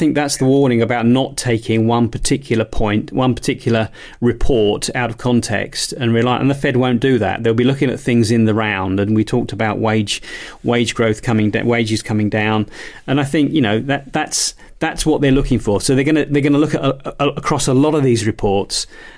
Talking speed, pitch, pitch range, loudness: 225 wpm, 120 Hz, 110-140 Hz, -16 LUFS